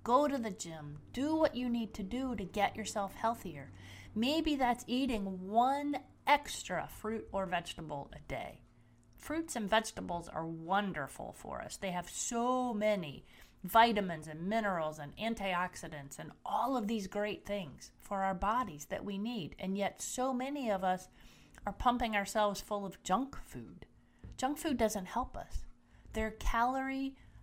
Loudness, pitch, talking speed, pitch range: -36 LUFS, 210 Hz, 160 wpm, 185-245 Hz